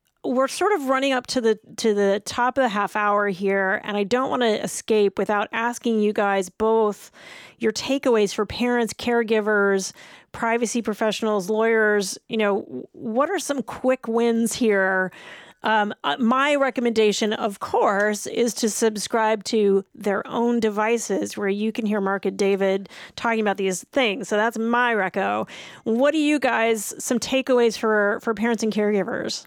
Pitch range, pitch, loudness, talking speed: 205-240 Hz, 220 Hz, -22 LUFS, 165 wpm